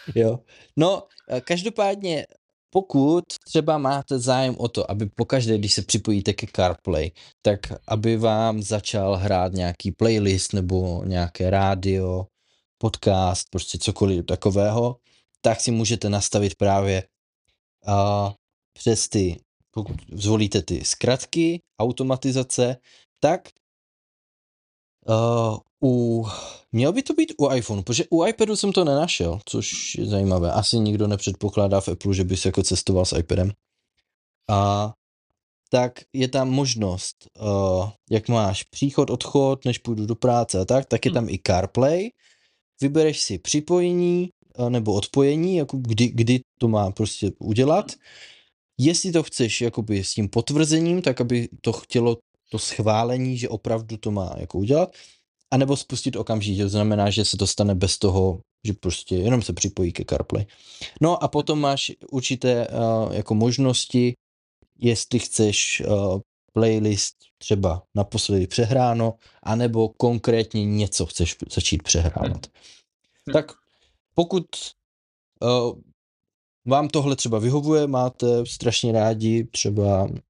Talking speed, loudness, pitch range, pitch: 130 wpm, -22 LUFS, 100-130 Hz, 115 Hz